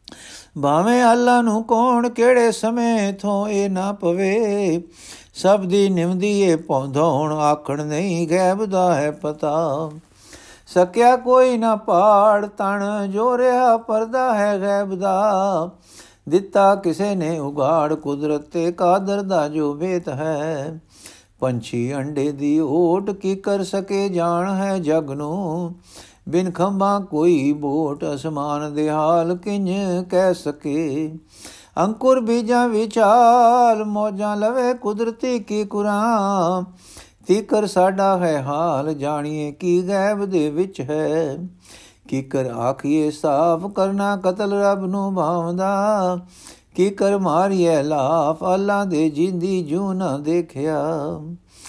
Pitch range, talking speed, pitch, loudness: 155-205 Hz, 115 wpm, 185 Hz, -19 LUFS